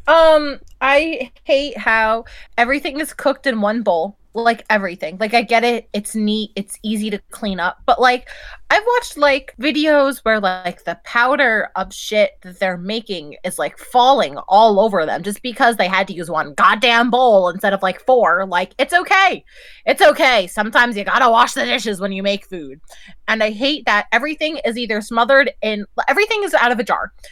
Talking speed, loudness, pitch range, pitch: 195 wpm, -16 LUFS, 200-275 Hz, 230 Hz